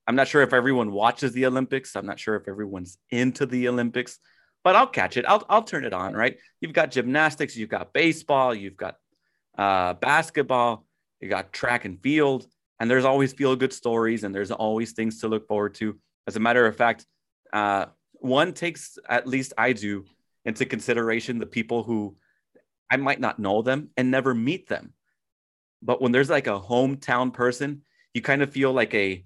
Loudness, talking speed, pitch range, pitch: -24 LUFS, 195 wpm, 110-135 Hz, 120 Hz